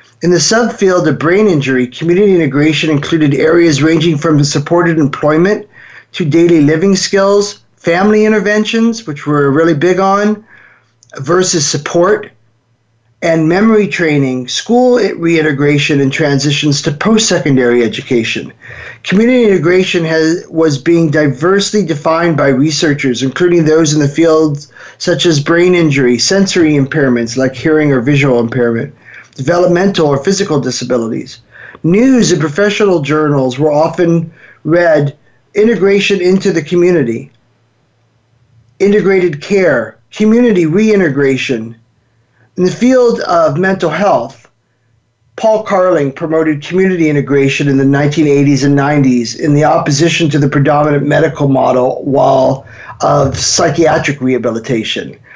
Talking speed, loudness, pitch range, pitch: 120 wpm, -10 LUFS, 135-180 Hz, 155 Hz